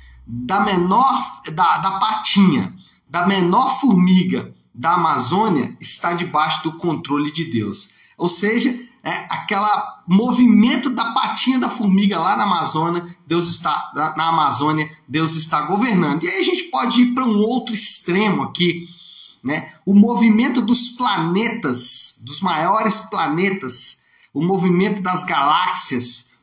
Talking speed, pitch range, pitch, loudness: 130 wpm, 160-220 Hz, 185 Hz, -17 LUFS